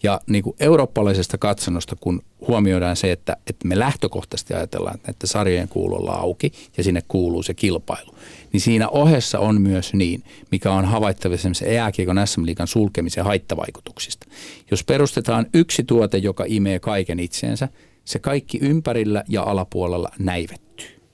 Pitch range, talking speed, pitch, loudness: 90-115 Hz, 145 wpm, 100 Hz, -21 LUFS